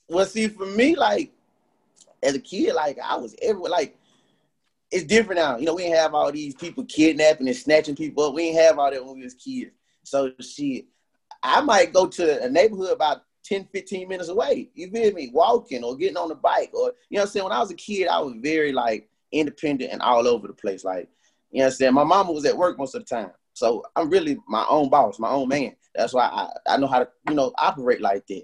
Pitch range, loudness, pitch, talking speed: 145-245 Hz, -22 LUFS, 180 Hz, 245 wpm